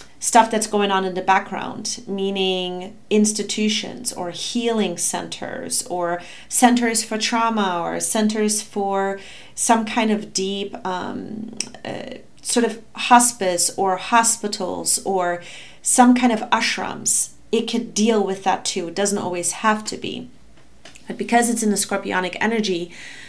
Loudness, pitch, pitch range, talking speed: -20 LUFS, 210 Hz, 190-230 Hz, 140 wpm